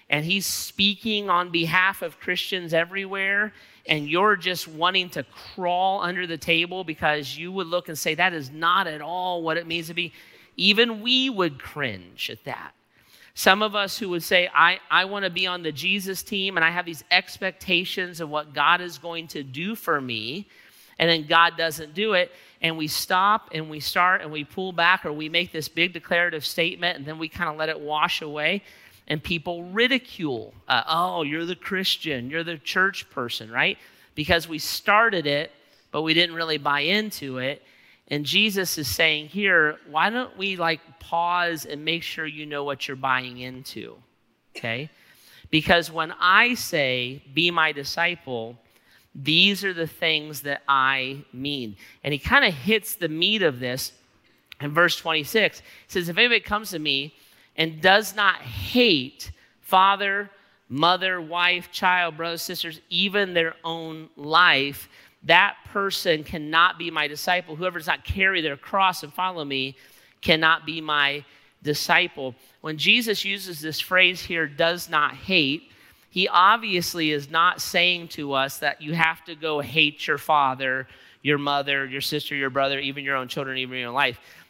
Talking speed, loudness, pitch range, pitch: 175 wpm, -23 LUFS, 145-185 Hz, 165 Hz